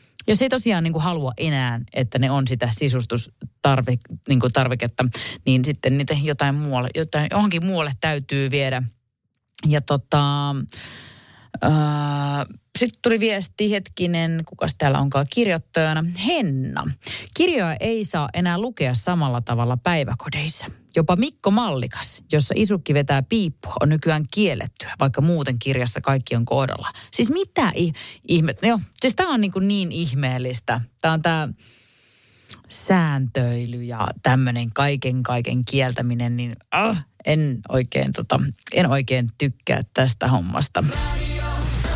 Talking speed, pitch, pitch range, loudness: 130 wpm, 140 Hz, 125-165 Hz, -21 LUFS